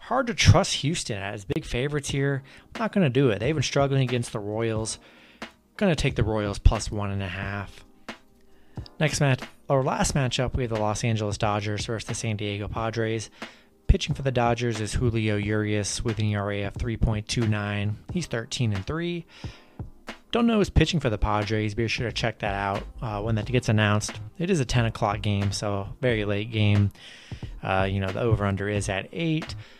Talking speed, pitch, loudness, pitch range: 195 wpm, 115 Hz, -26 LUFS, 105-135 Hz